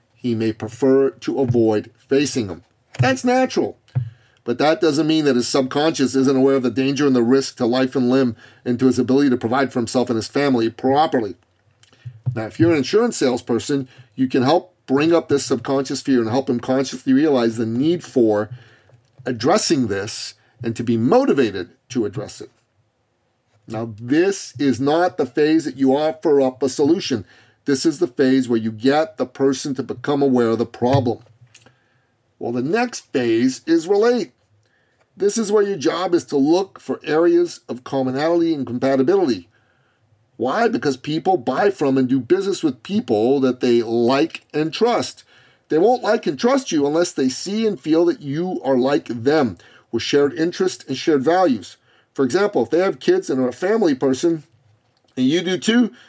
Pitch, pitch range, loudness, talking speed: 135 Hz, 120-165 Hz, -19 LUFS, 180 wpm